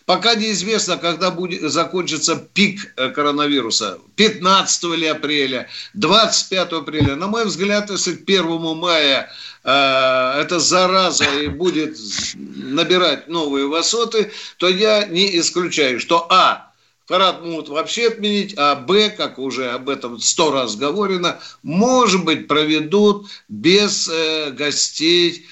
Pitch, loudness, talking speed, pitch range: 170 Hz, -17 LUFS, 120 wpm, 150-195 Hz